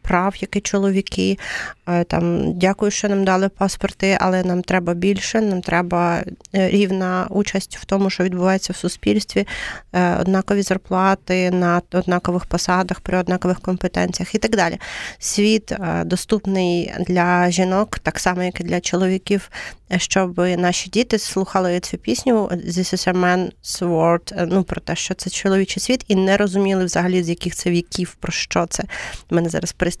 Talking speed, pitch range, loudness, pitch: 150 wpm, 180-195 Hz, -19 LUFS, 185 Hz